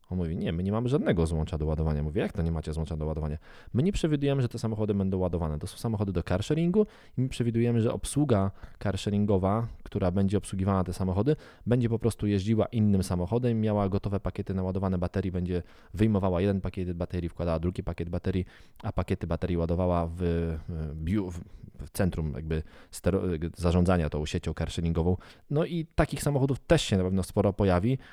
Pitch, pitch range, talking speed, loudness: 95 Hz, 85-110 Hz, 185 wpm, -29 LUFS